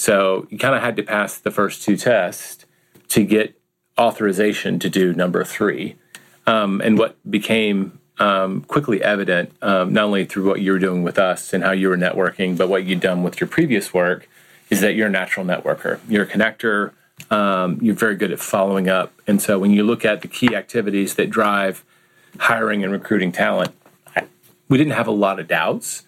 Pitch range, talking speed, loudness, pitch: 95-105 Hz, 200 wpm, -19 LUFS, 100 Hz